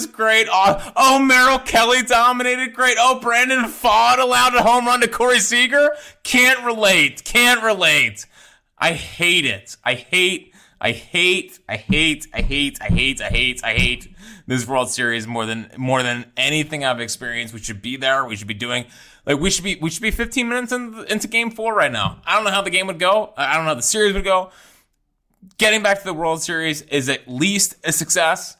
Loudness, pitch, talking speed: -17 LUFS, 185 Hz, 205 wpm